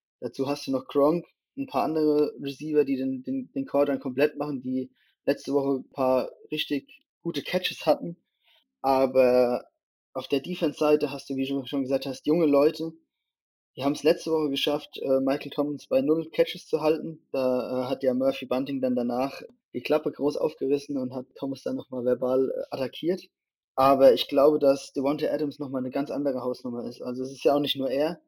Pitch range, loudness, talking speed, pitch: 130-150 Hz, -26 LUFS, 190 wpm, 140 Hz